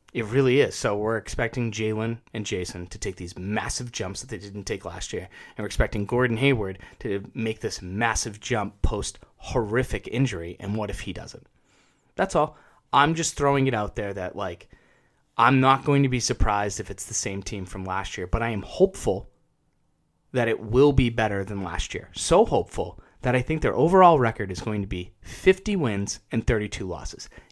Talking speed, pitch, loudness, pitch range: 200 wpm, 110 Hz, -25 LUFS, 100-125 Hz